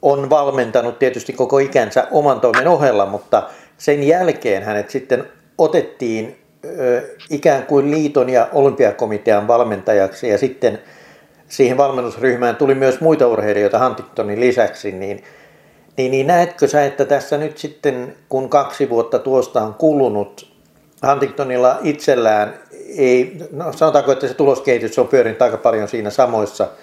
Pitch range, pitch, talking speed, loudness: 125-150 Hz, 135 Hz, 135 wpm, -16 LUFS